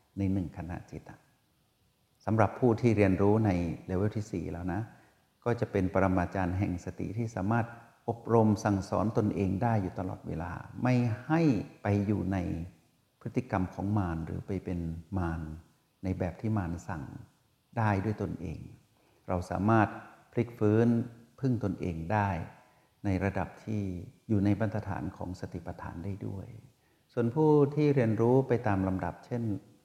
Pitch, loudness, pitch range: 105 Hz, -31 LUFS, 95-120 Hz